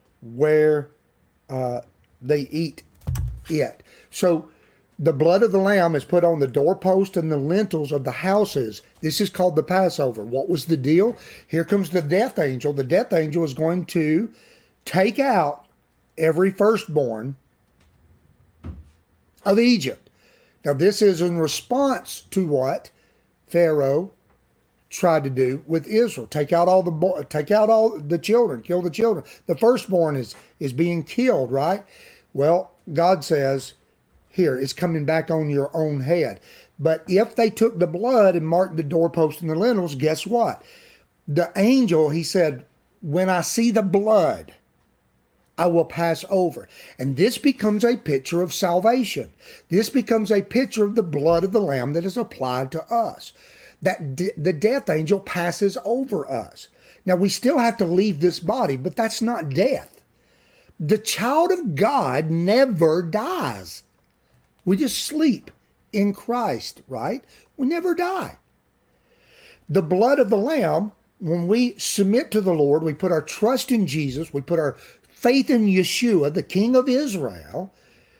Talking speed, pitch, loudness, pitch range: 155 wpm, 180 Hz, -21 LUFS, 155-215 Hz